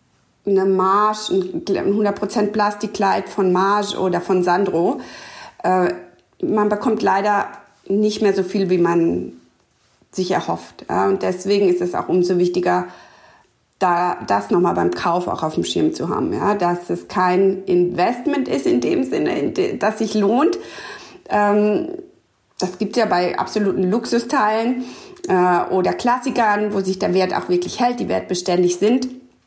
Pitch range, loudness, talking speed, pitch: 180-215 Hz, -19 LUFS, 155 wpm, 195 Hz